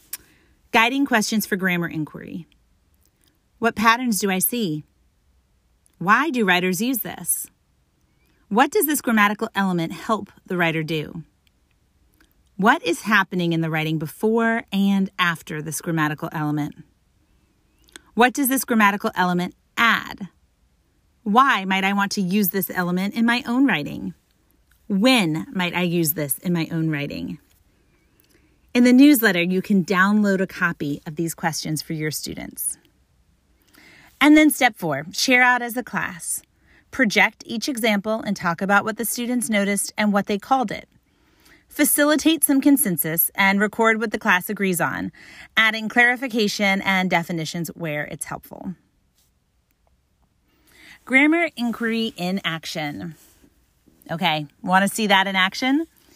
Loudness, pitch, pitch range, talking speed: -20 LUFS, 195 Hz, 165-230 Hz, 140 wpm